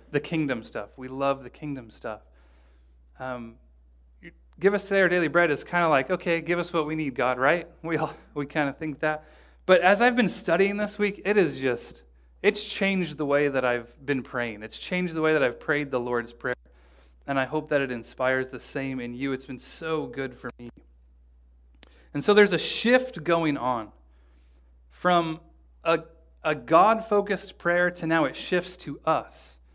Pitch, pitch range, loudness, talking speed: 140 Hz, 110-170 Hz, -26 LUFS, 190 wpm